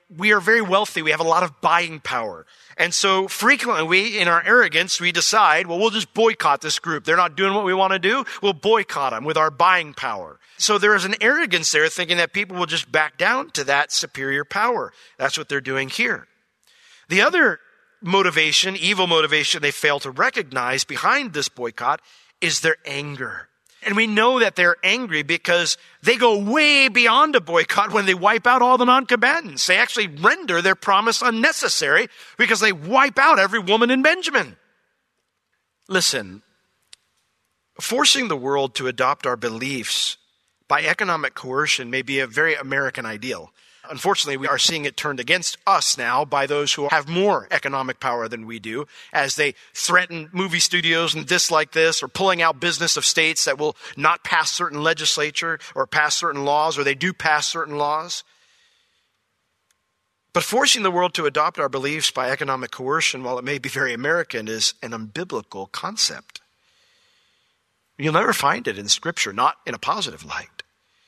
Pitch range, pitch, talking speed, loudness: 145-210 Hz, 170 Hz, 180 wpm, -19 LUFS